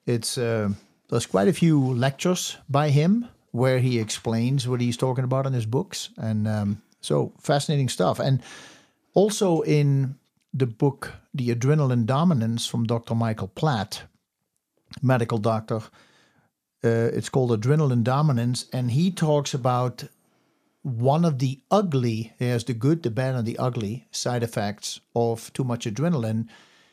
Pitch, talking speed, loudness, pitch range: 125 Hz, 145 wpm, -24 LUFS, 115-145 Hz